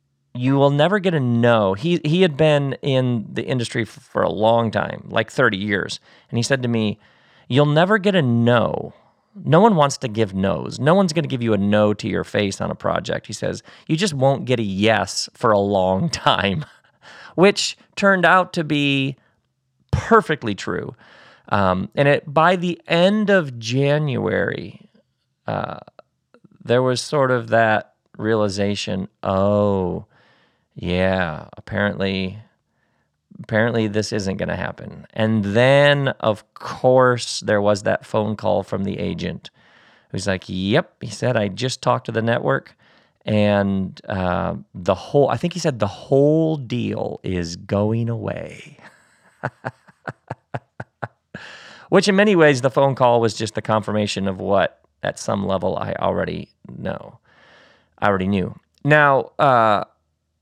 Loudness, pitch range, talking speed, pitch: -19 LUFS, 105-145 Hz, 155 wpm, 115 Hz